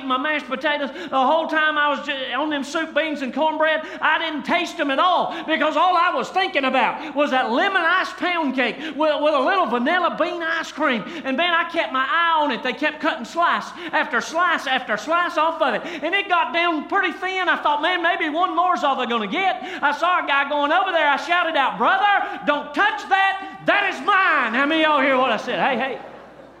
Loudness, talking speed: -20 LUFS, 230 wpm